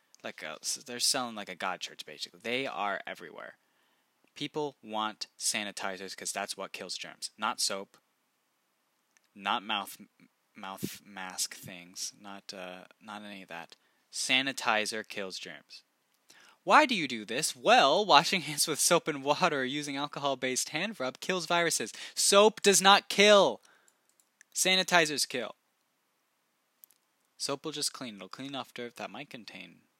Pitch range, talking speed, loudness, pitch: 105-170 Hz, 145 wpm, -28 LUFS, 135 Hz